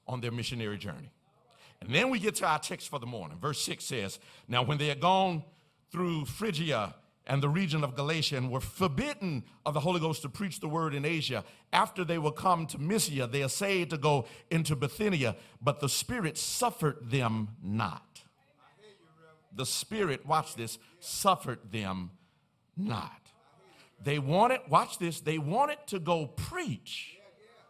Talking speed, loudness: 165 wpm, -31 LUFS